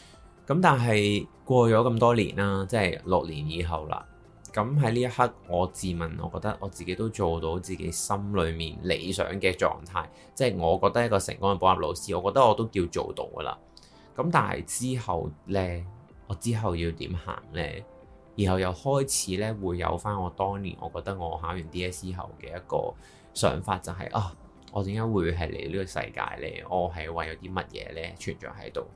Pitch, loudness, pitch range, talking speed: 95 Hz, -28 LUFS, 85-105 Hz, 290 characters per minute